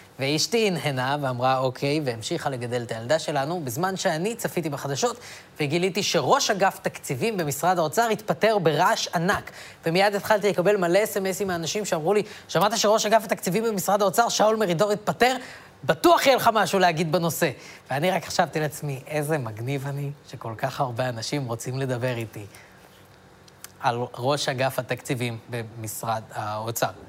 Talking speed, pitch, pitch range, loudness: 145 wpm, 160 Hz, 130-200 Hz, -24 LUFS